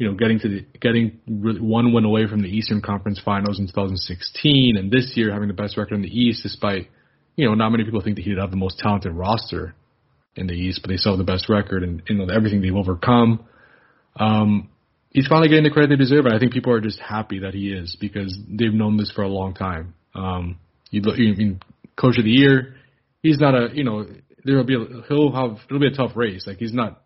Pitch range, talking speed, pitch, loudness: 100-120 Hz, 235 wpm, 110 Hz, -20 LUFS